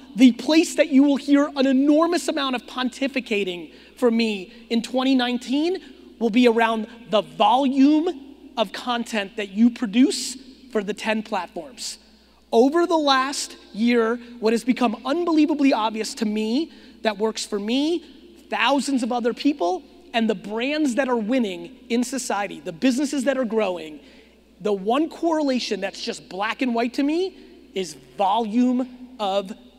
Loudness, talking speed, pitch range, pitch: -22 LUFS, 150 wpm, 220-280 Hz, 250 Hz